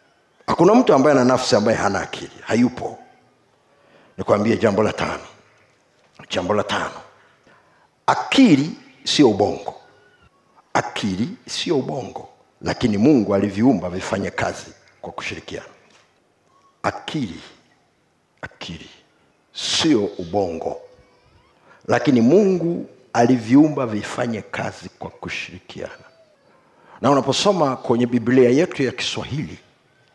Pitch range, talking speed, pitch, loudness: 125-170 Hz, 95 wpm, 135 Hz, -19 LUFS